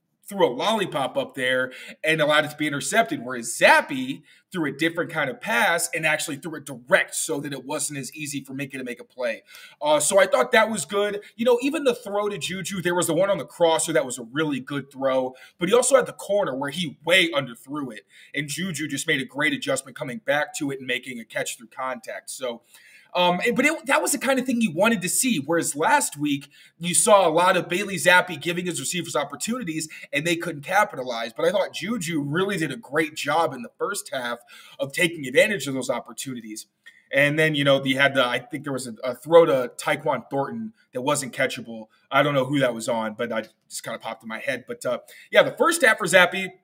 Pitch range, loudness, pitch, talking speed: 140-205 Hz, -23 LUFS, 165 Hz, 245 wpm